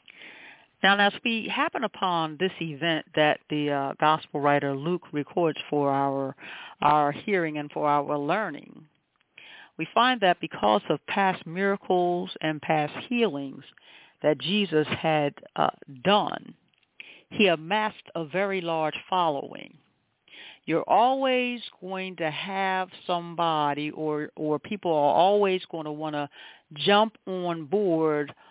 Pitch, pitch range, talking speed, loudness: 165 Hz, 150-195 Hz, 130 wpm, -26 LUFS